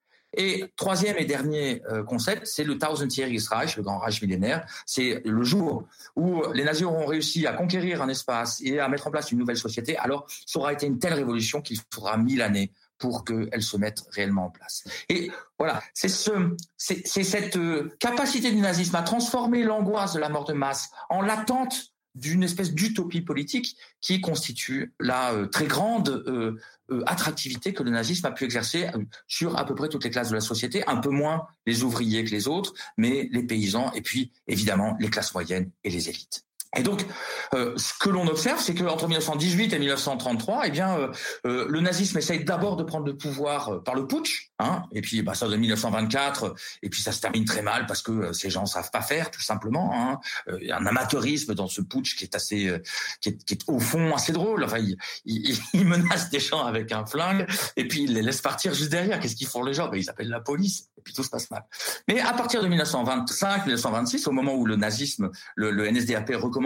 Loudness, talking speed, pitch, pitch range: -26 LUFS, 220 wpm, 145 Hz, 115-180 Hz